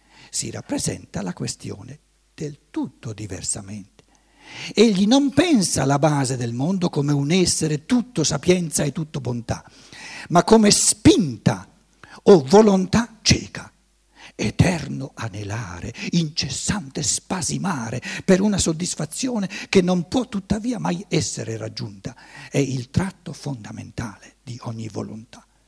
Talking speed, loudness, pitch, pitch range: 115 wpm, -21 LUFS, 155 Hz, 120-195 Hz